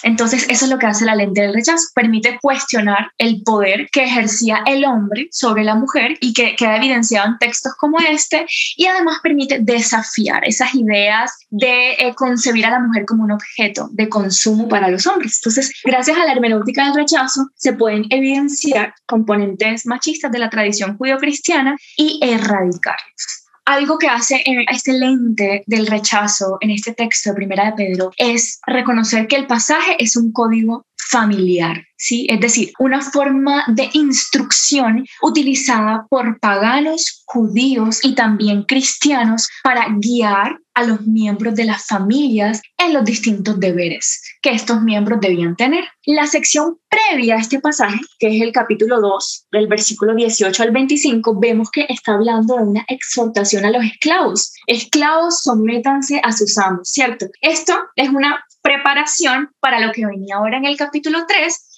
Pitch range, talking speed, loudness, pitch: 220-275 Hz, 160 wpm, -15 LUFS, 240 Hz